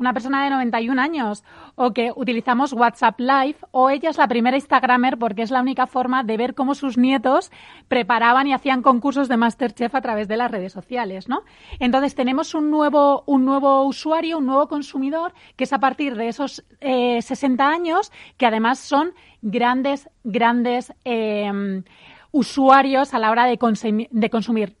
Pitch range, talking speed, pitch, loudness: 235-275 Hz, 175 wpm, 260 Hz, -19 LUFS